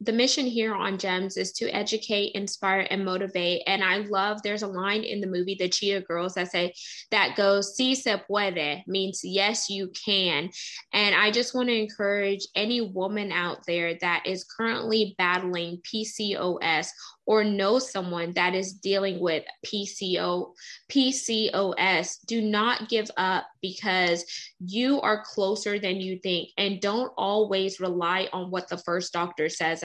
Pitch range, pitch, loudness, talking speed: 180-210 Hz, 195 Hz, -26 LUFS, 160 wpm